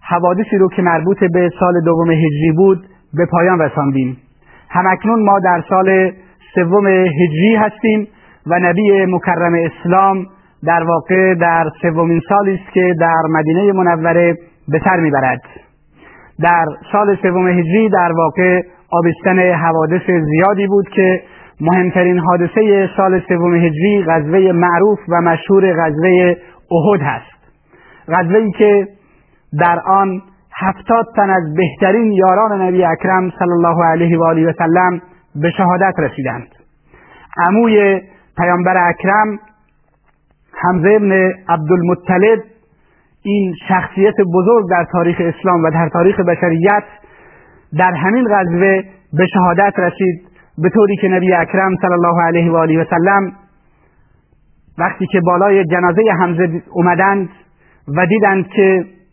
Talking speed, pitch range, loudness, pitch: 125 wpm, 170-195 Hz, -13 LUFS, 180 Hz